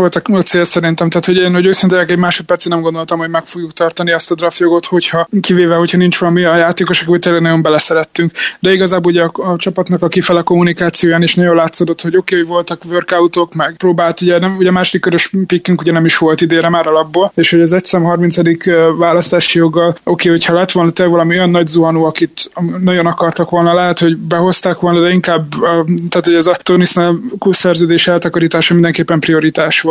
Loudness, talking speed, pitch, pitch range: -11 LUFS, 205 wpm, 175 Hz, 170-180 Hz